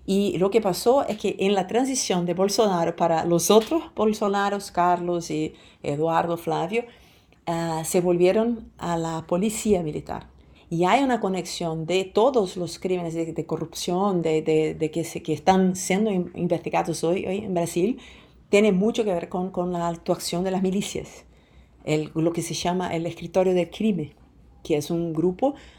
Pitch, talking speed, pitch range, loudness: 180 Hz, 170 wpm, 165-200 Hz, -24 LUFS